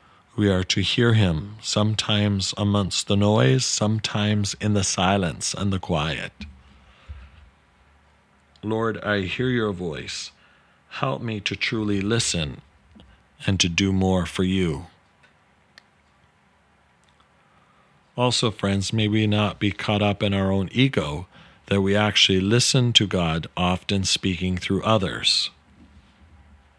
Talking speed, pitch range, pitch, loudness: 120 wpm, 90-105 Hz, 100 Hz, -22 LUFS